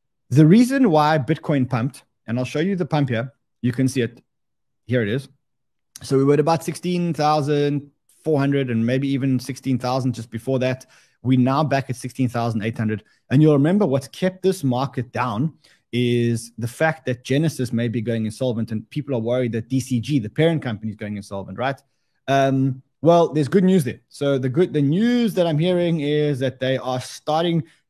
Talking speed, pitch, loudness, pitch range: 200 wpm, 135 Hz, -21 LUFS, 125-150 Hz